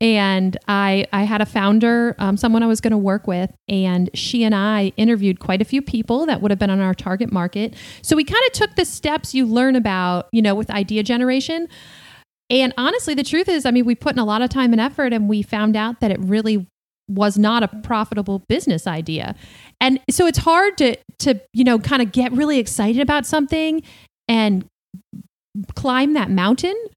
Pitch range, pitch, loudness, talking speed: 200-260 Hz, 225 Hz, -18 LUFS, 210 wpm